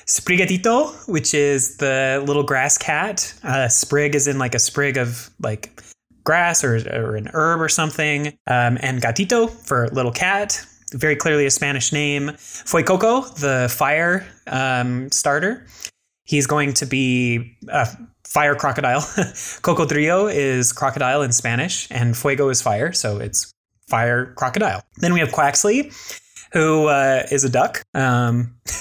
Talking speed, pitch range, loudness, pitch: 145 wpm, 125-155 Hz, -19 LUFS, 140 Hz